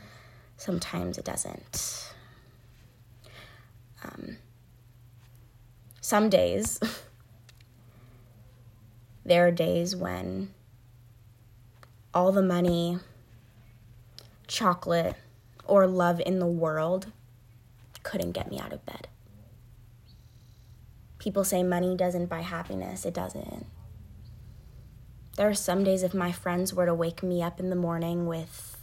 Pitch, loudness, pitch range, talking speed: 120 Hz, -28 LUFS, 115-170 Hz, 100 wpm